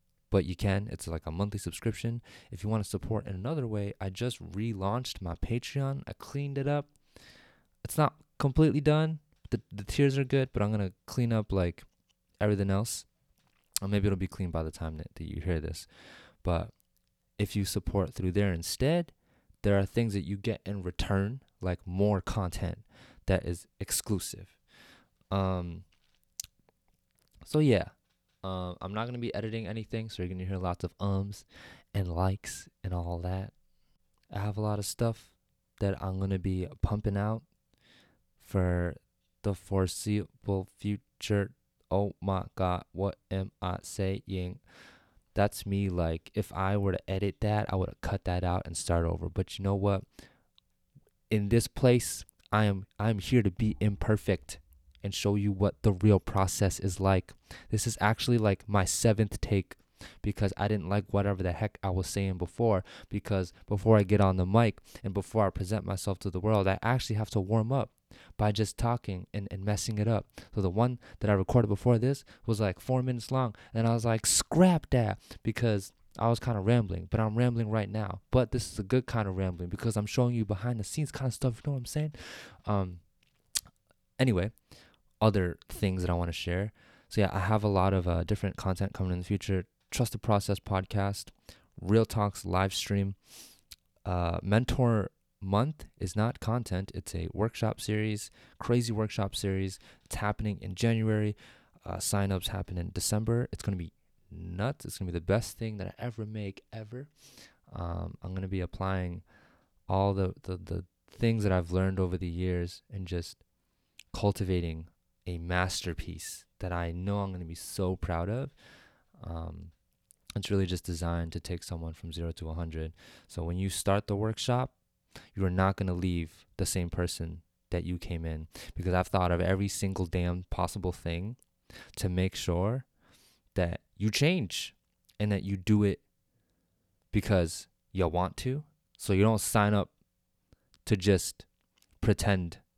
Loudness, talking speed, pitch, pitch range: -31 LUFS, 180 wpm, 100 Hz, 90-110 Hz